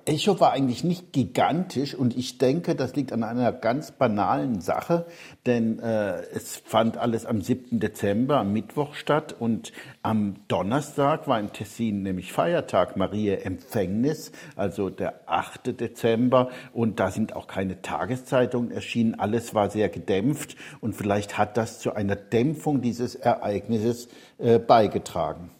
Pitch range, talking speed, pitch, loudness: 105-130 Hz, 145 wpm, 120 Hz, -26 LUFS